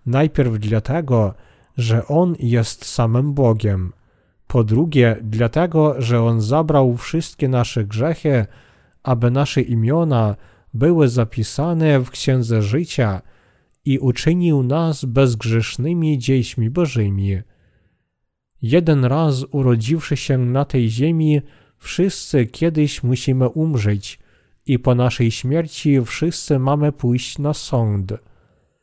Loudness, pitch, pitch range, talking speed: -18 LUFS, 130 Hz, 115-150 Hz, 105 wpm